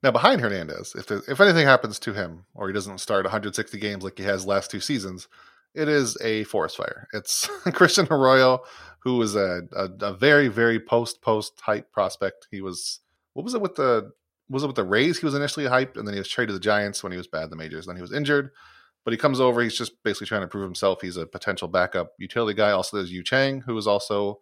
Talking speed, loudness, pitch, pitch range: 250 wpm, -23 LUFS, 105 Hz, 95-130 Hz